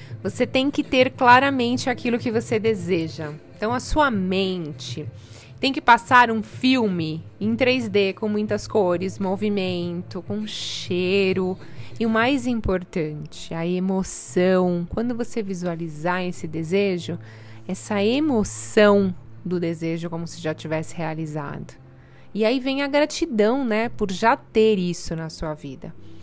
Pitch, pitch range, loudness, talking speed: 190 Hz, 165-230 Hz, -22 LUFS, 135 wpm